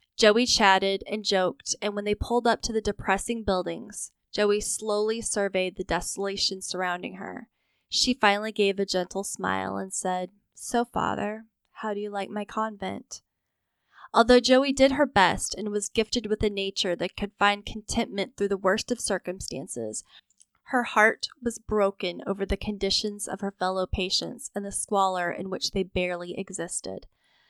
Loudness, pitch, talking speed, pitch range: -26 LUFS, 200 Hz, 165 wpm, 190-215 Hz